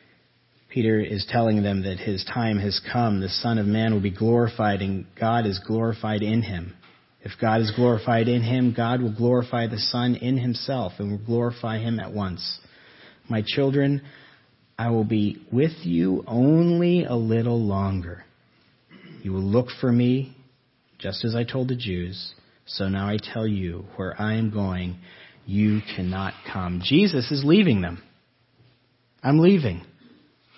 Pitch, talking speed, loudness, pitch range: 110 Hz, 160 wpm, -24 LUFS, 100-125 Hz